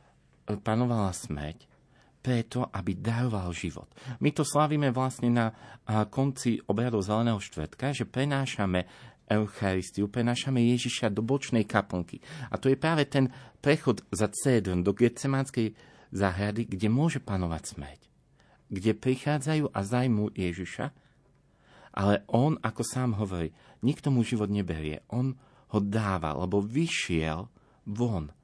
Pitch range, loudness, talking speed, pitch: 100-130 Hz, -29 LUFS, 120 wpm, 115 Hz